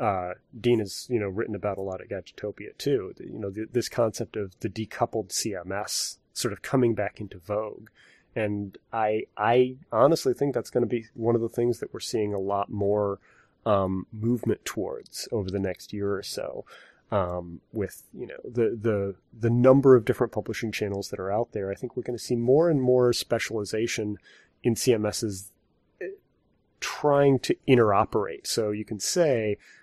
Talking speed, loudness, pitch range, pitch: 180 wpm, -27 LUFS, 100-120 Hz, 110 Hz